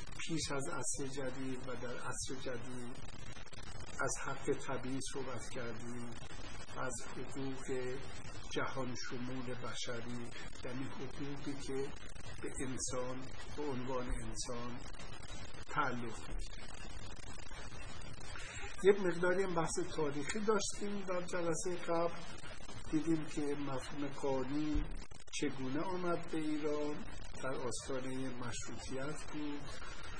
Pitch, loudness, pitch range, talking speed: 130 Hz, -41 LUFS, 120-150 Hz, 95 wpm